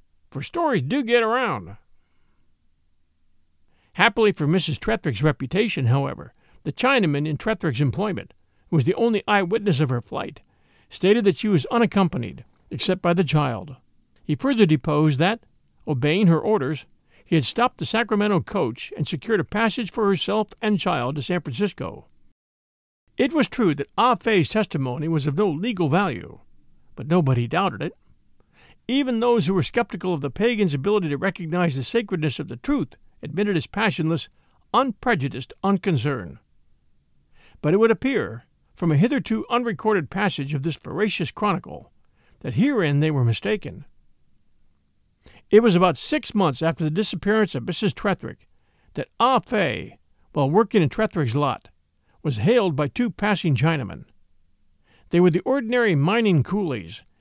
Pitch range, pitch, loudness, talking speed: 140-215 Hz, 175 Hz, -22 LUFS, 150 wpm